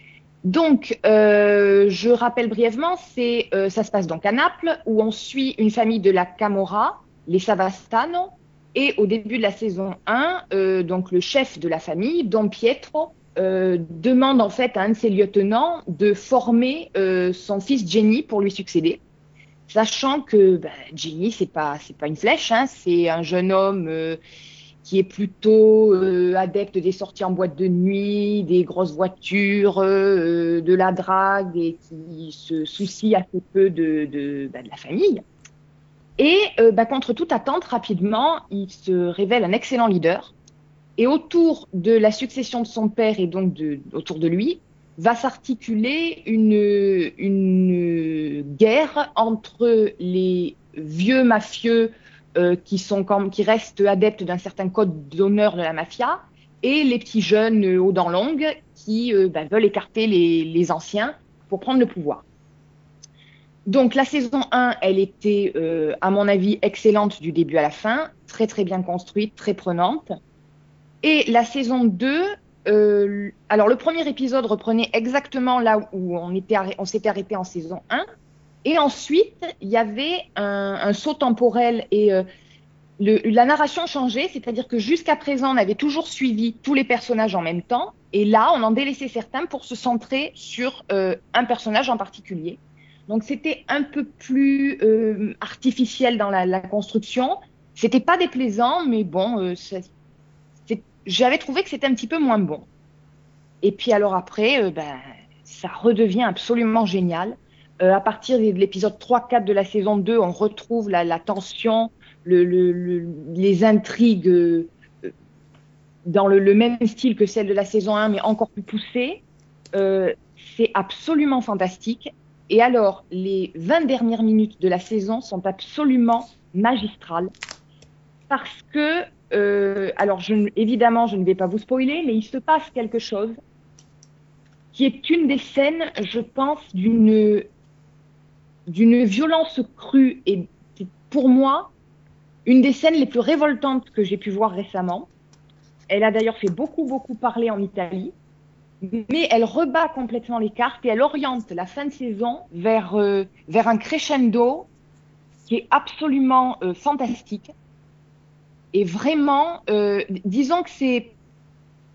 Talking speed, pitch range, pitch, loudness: 160 wpm, 180-240 Hz, 210 Hz, -20 LUFS